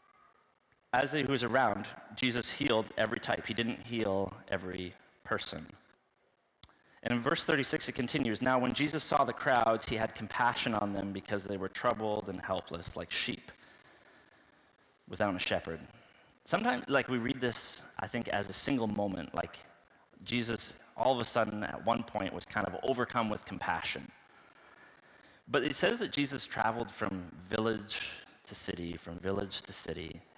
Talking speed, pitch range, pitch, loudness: 160 wpm, 95-125 Hz, 110 Hz, -34 LUFS